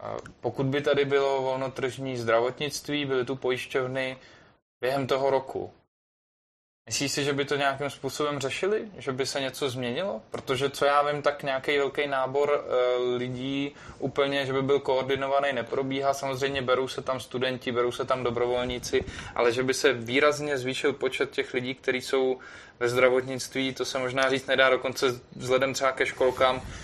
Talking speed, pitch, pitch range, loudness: 160 wpm, 135 Hz, 130-140 Hz, -27 LUFS